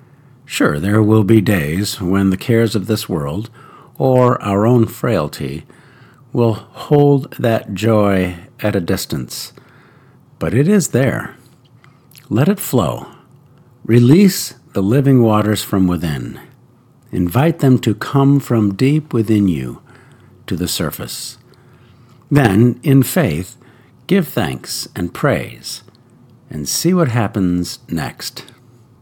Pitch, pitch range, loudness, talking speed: 120 Hz, 105-135 Hz, -16 LUFS, 120 wpm